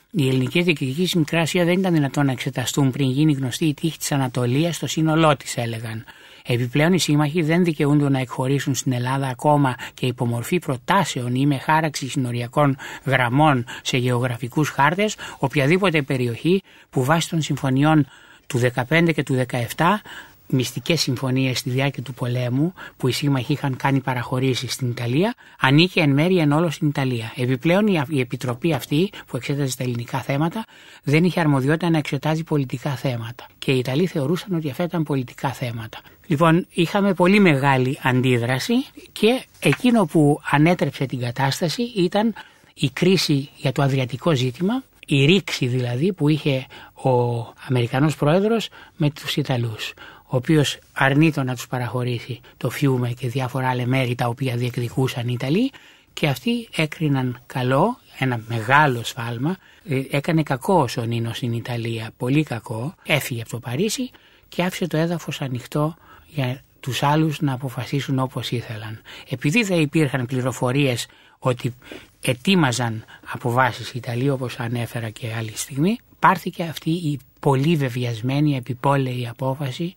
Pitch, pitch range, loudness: 140 Hz, 125-160 Hz, -21 LUFS